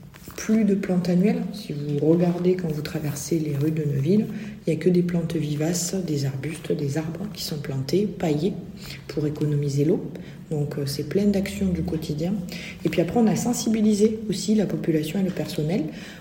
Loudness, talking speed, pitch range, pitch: -24 LUFS, 185 wpm, 155-195 Hz, 170 Hz